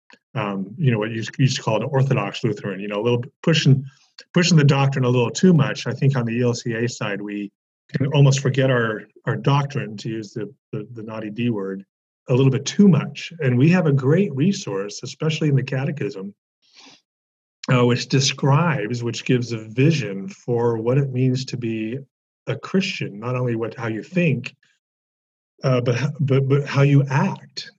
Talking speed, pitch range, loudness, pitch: 190 wpm, 115-140 Hz, -21 LUFS, 130 Hz